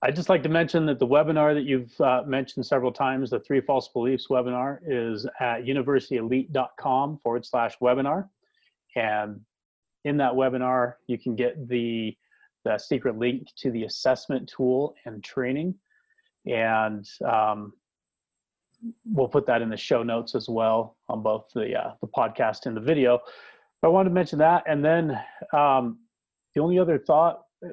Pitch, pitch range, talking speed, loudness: 130 Hz, 115-145 Hz, 160 wpm, -25 LUFS